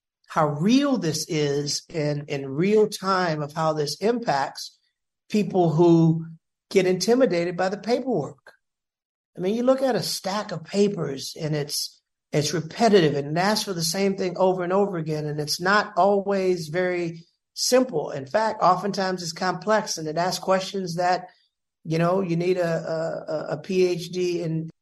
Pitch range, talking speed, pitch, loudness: 160-195 Hz, 165 wpm, 180 Hz, -24 LUFS